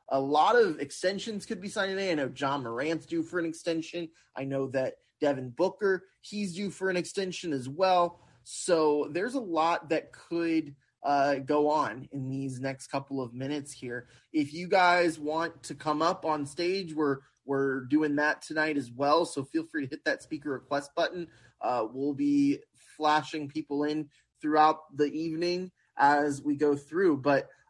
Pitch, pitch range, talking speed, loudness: 155 Hz, 140-175 Hz, 180 wpm, -30 LUFS